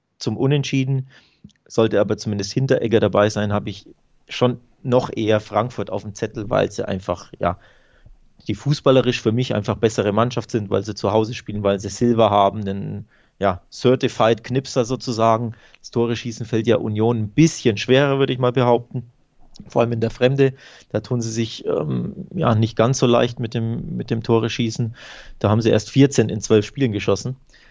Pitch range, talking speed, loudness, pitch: 105-125 Hz, 185 wpm, -20 LUFS, 115 Hz